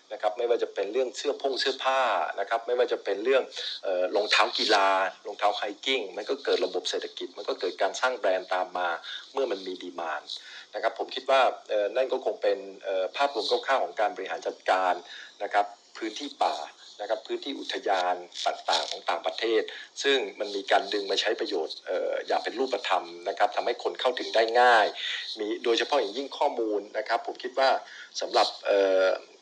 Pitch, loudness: 360 Hz, -28 LUFS